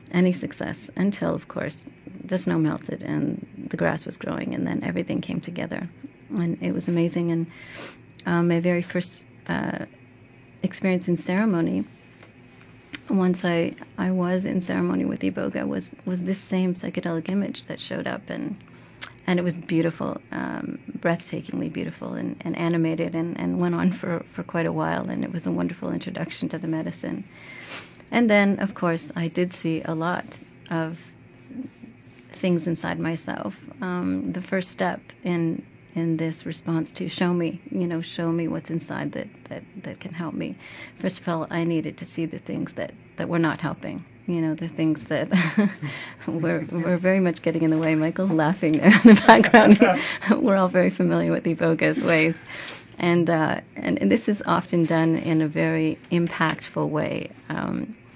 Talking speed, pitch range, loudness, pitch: 175 wpm, 160-180 Hz, -24 LUFS, 170 Hz